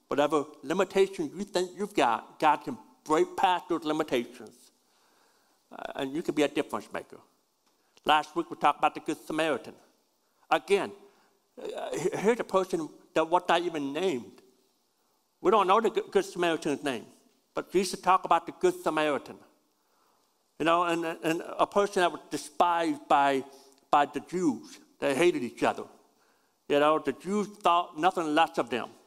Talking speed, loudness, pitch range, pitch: 165 wpm, -28 LUFS, 150-195 Hz, 170 Hz